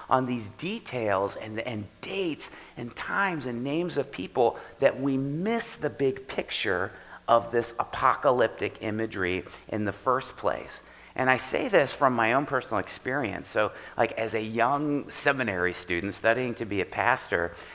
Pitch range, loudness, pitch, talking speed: 110-140 Hz, -28 LUFS, 125 Hz, 160 wpm